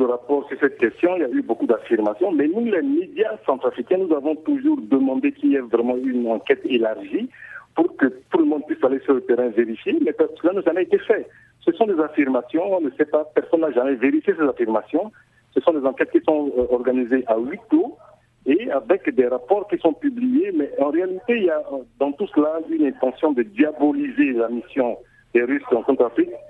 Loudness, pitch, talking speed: -21 LUFS, 160 Hz, 210 wpm